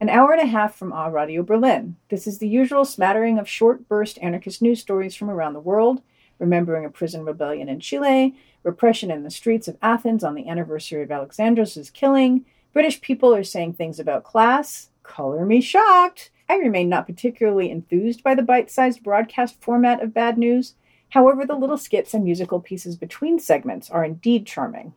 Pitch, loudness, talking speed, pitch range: 215 Hz, -20 LUFS, 185 wpm, 175-250 Hz